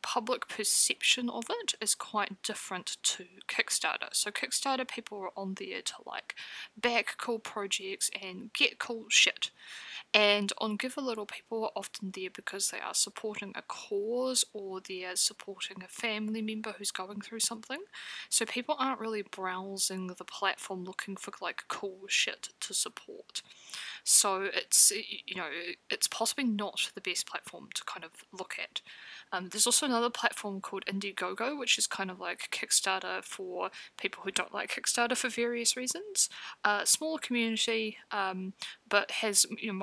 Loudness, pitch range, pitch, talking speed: -31 LUFS, 195-245 Hz, 220 Hz, 165 wpm